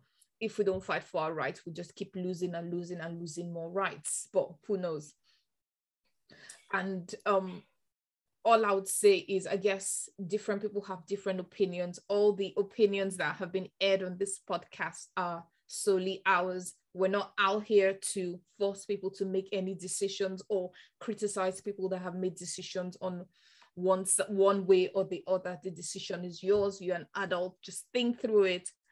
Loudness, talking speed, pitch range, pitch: -32 LUFS, 170 wpm, 180-200 Hz, 190 Hz